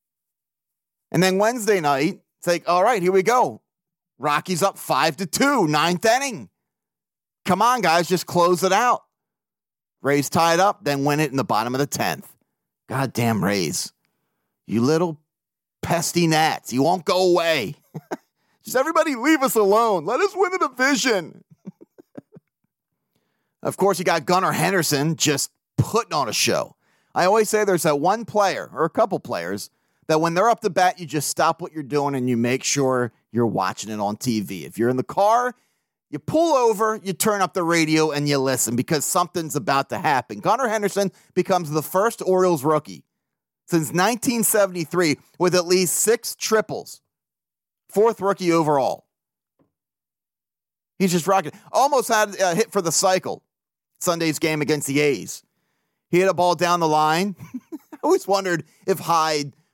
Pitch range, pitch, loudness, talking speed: 150-200 Hz, 175 Hz, -21 LUFS, 165 wpm